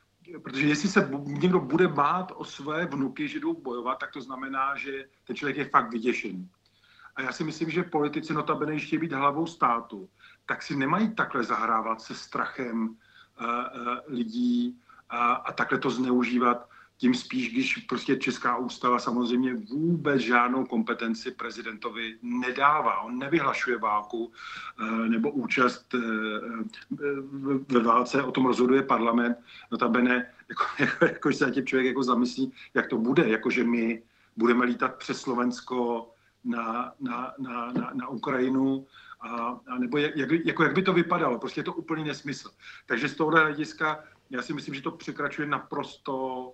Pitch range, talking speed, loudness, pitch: 120-155 Hz, 155 wpm, -28 LUFS, 135 Hz